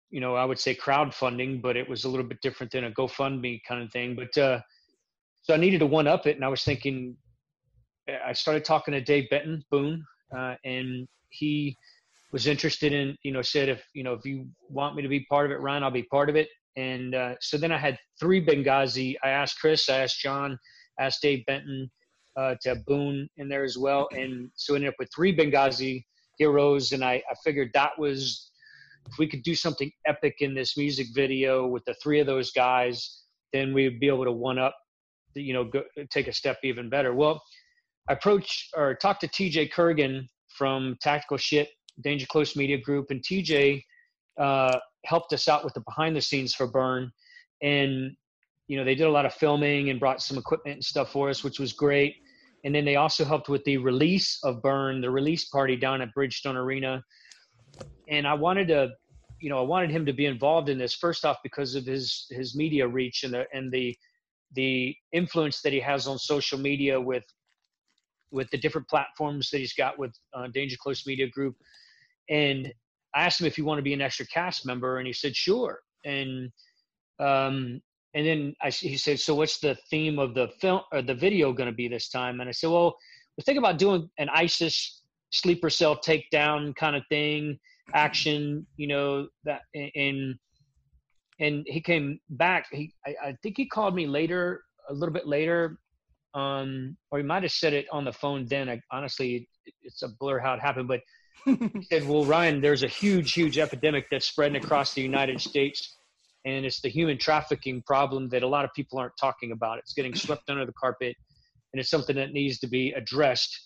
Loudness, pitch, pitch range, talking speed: -27 LUFS, 140 Hz, 130-150 Hz, 205 wpm